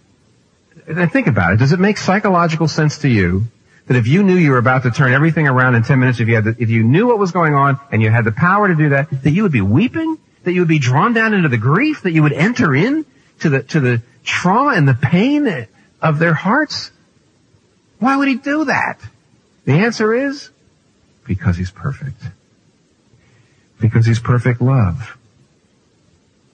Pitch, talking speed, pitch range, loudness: 150 Hz, 200 wpm, 125-185 Hz, -15 LUFS